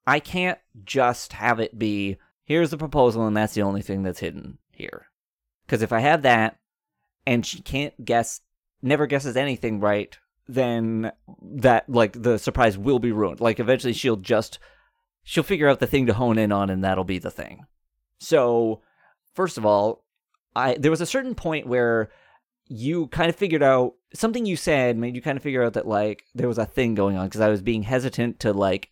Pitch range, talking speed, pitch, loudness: 105-140 Hz, 200 wpm, 120 Hz, -23 LUFS